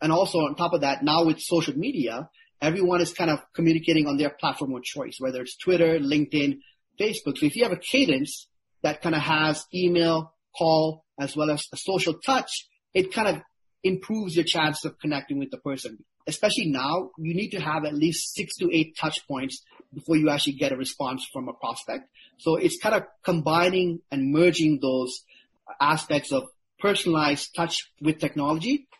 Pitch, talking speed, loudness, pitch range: 160 Hz, 185 wpm, -25 LUFS, 145-175 Hz